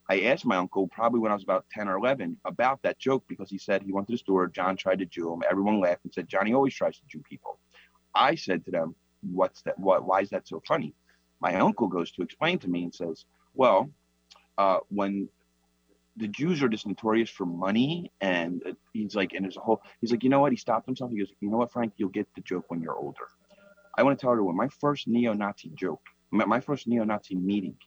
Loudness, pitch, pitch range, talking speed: -28 LUFS, 105 Hz, 95-120 Hz, 240 wpm